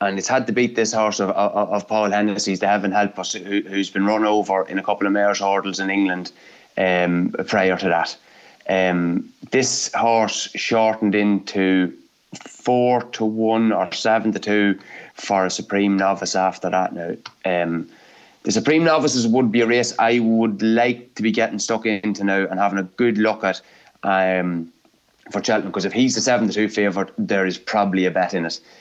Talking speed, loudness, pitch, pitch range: 195 wpm, -20 LUFS, 100 Hz, 95-110 Hz